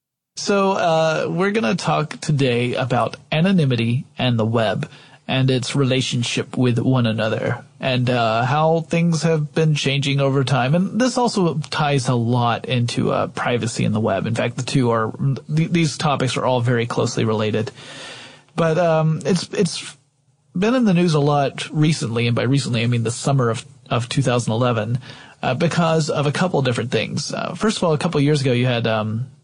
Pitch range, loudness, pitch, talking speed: 125-160 Hz, -19 LUFS, 140 Hz, 185 wpm